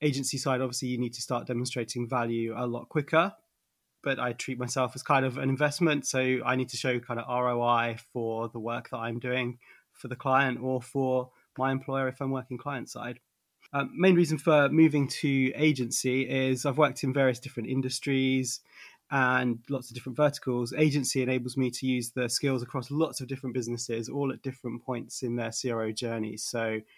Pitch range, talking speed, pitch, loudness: 120-135 Hz, 195 wpm, 130 Hz, -29 LUFS